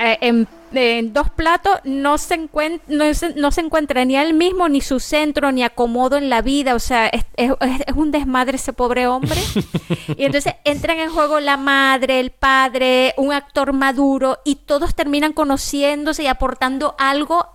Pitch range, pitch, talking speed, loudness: 255-300 Hz, 275 Hz, 180 wpm, -17 LUFS